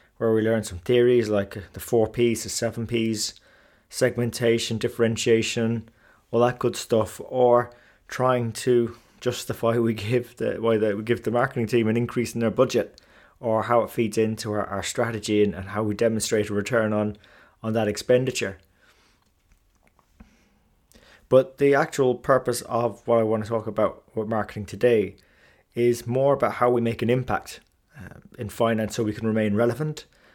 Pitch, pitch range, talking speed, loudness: 115 Hz, 110-120 Hz, 170 wpm, -24 LUFS